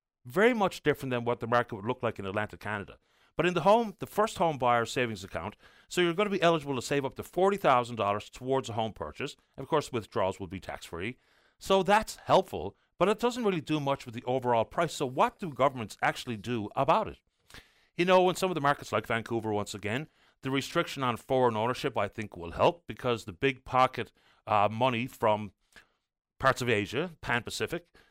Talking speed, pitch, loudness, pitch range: 210 wpm, 125 Hz, -30 LUFS, 110-165 Hz